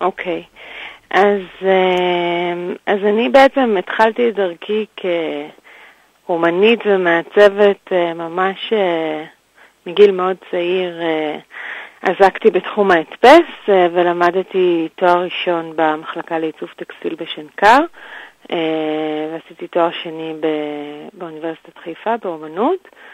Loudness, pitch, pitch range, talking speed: -16 LUFS, 180 Hz, 165-205 Hz, 80 wpm